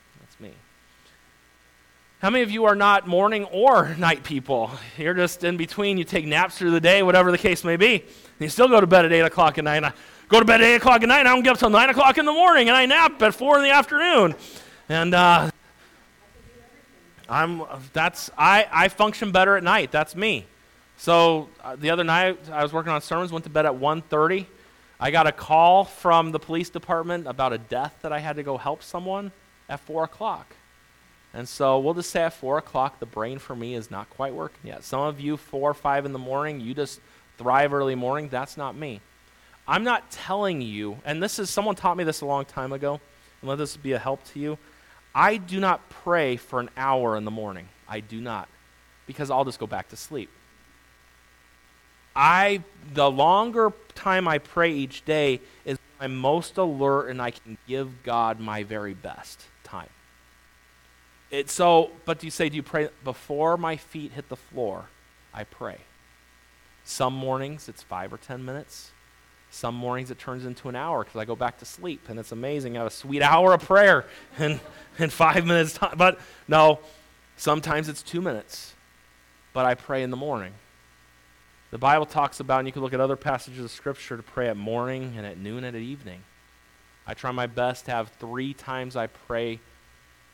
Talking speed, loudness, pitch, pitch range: 205 wpm, -22 LUFS, 140 Hz, 115-165 Hz